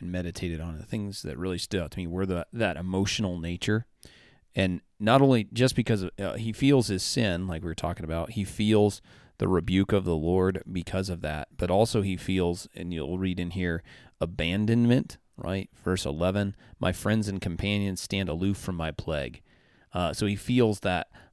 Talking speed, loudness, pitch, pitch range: 195 wpm, -28 LUFS, 95 Hz, 90-105 Hz